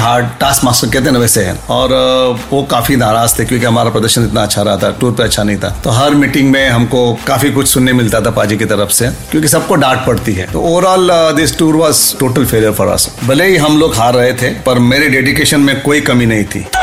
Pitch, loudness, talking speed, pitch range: 125 Hz, -10 LUFS, 240 wpm, 115-140 Hz